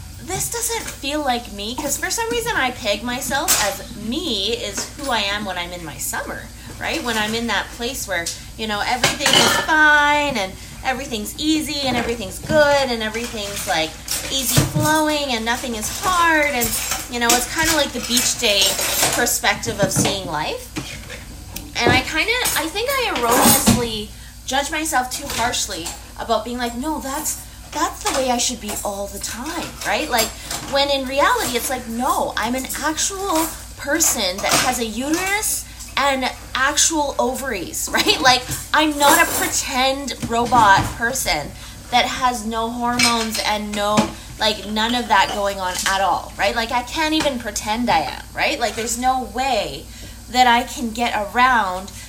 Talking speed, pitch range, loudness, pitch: 170 wpm, 225-295 Hz, -19 LUFS, 250 Hz